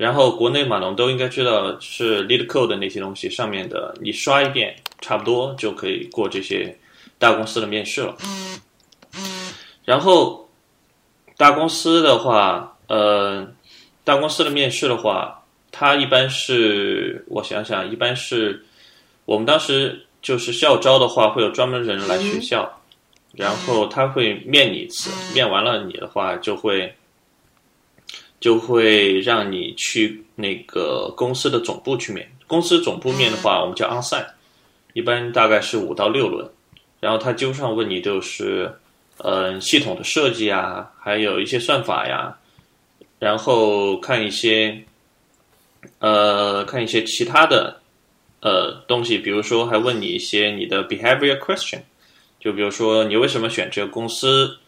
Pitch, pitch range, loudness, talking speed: 125 Hz, 110-140 Hz, -19 LUFS, 250 characters per minute